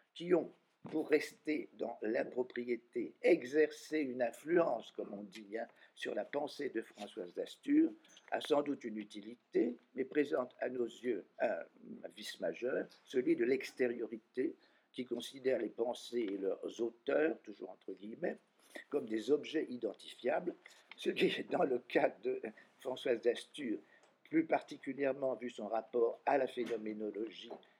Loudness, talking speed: -38 LUFS, 145 wpm